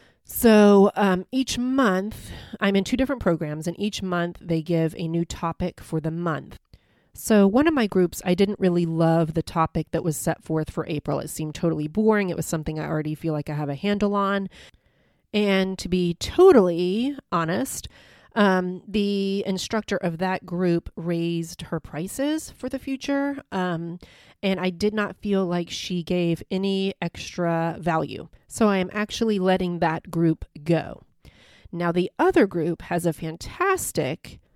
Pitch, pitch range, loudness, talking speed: 180 Hz, 165-205 Hz, -24 LUFS, 170 wpm